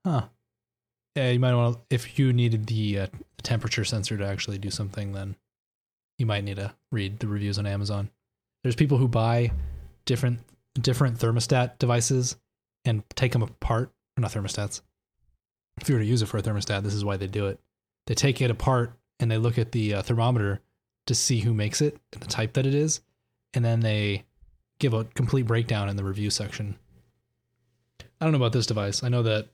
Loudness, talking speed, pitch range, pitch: -26 LUFS, 200 wpm, 105-125 Hz, 115 Hz